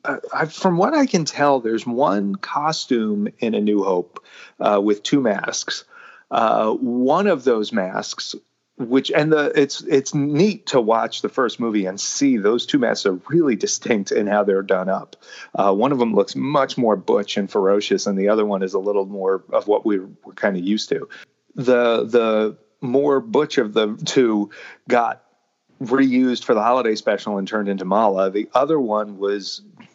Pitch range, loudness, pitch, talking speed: 100-145 Hz, -20 LUFS, 115 Hz, 190 wpm